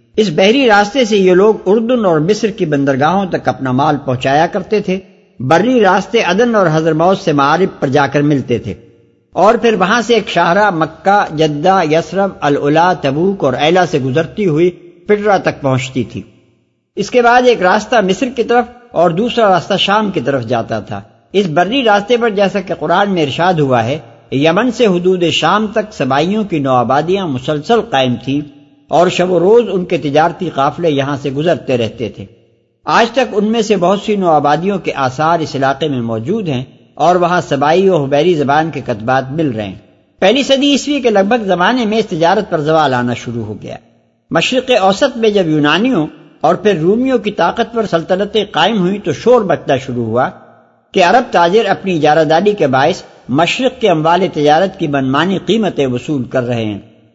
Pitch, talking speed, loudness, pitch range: 170 Hz, 190 wpm, -12 LUFS, 140-205 Hz